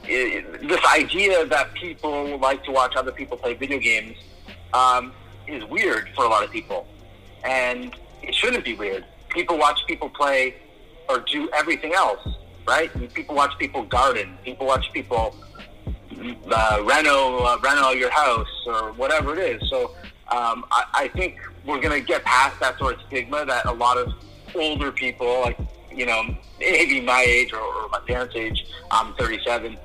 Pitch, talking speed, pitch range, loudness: 125 Hz, 175 wpm, 105-135 Hz, -21 LUFS